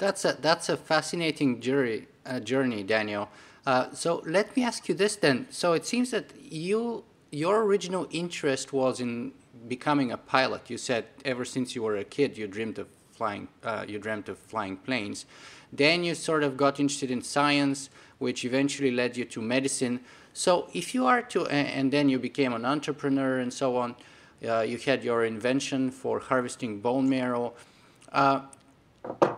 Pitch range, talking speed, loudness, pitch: 125-150 Hz, 175 wpm, -28 LUFS, 135 Hz